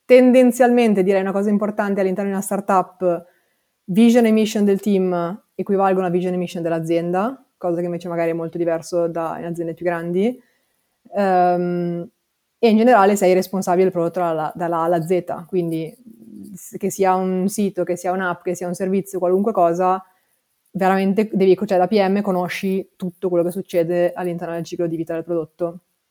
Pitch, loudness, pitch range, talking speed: 185 Hz, -19 LUFS, 175-195 Hz, 170 wpm